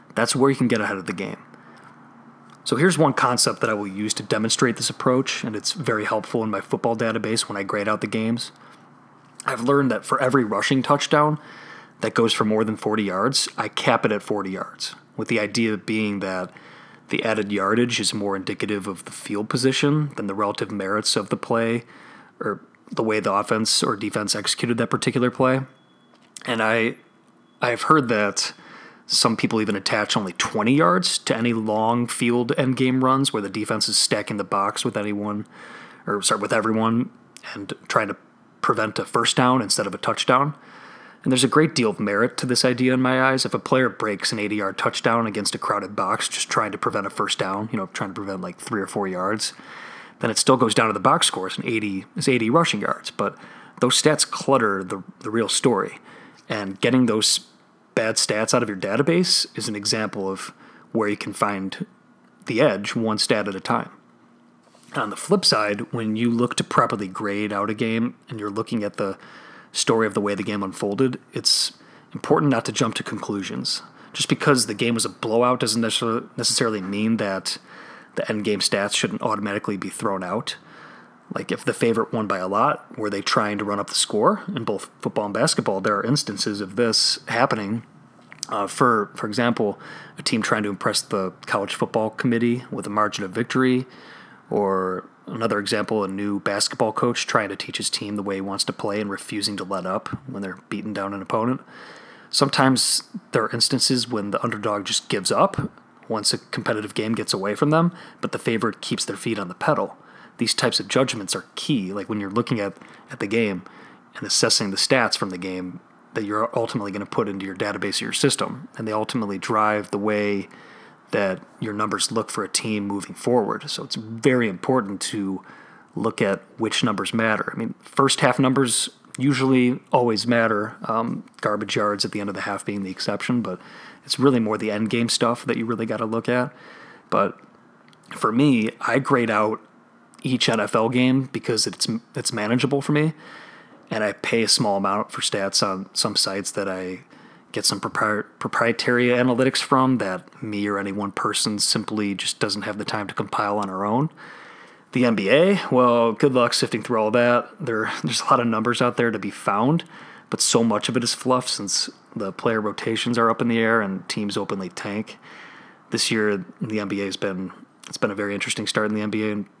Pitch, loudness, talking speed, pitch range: 110 Hz, -22 LUFS, 205 wpm, 105-125 Hz